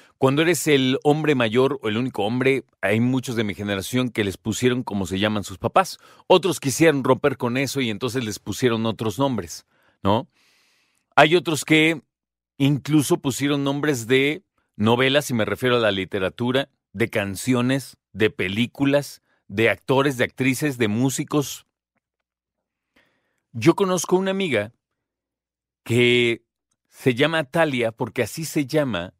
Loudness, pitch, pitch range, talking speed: -21 LUFS, 130 Hz, 115-145 Hz, 145 wpm